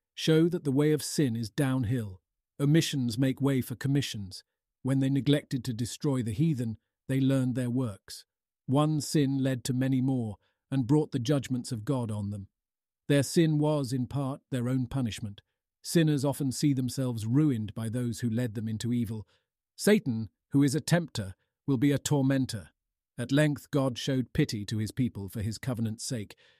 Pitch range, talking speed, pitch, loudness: 115-140 Hz, 180 wpm, 130 Hz, -29 LUFS